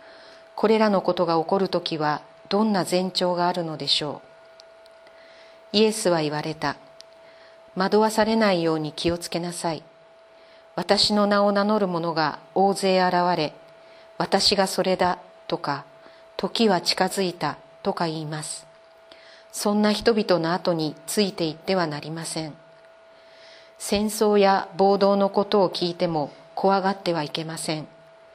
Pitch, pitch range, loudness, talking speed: 185 Hz, 165-210 Hz, -23 LUFS, 265 characters per minute